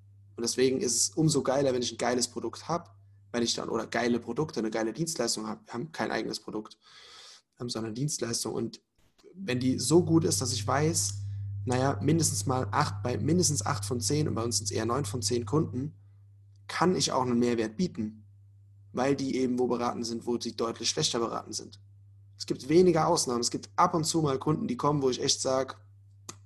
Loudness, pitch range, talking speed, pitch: -29 LUFS, 105-135 Hz, 210 wpm, 120 Hz